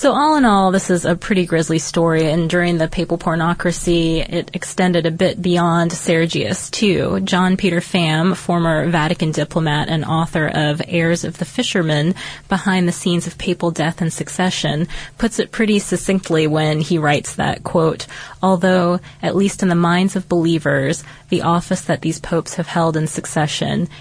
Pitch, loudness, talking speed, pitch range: 170 Hz, -17 LUFS, 170 wpm, 160-185 Hz